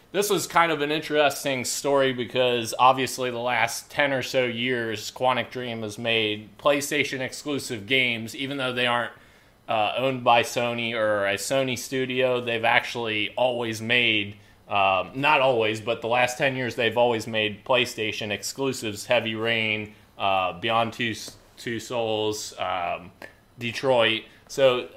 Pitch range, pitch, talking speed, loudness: 110-130 Hz, 120 Hz, 145 wpm, -24 LUFS